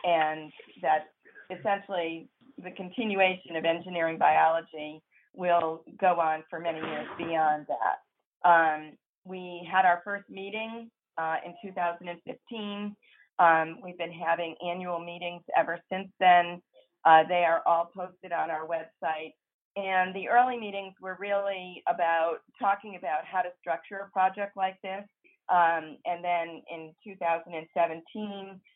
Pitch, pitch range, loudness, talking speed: 175 Hz, 165-195 Hz, -28 LUFS, 130 wpm